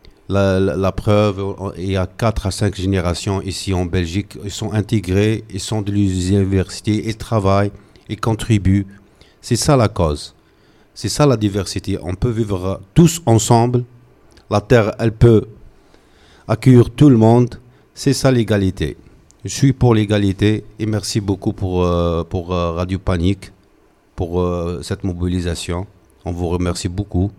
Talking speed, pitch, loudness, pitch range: 150 wpm, 100 Hz, -17 LUFS, 95-110 Hz